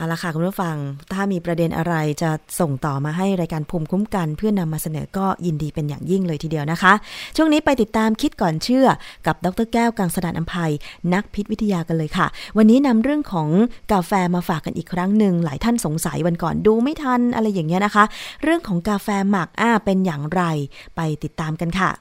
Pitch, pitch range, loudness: 180 Hz, 165-210 Hz, -20 LUFS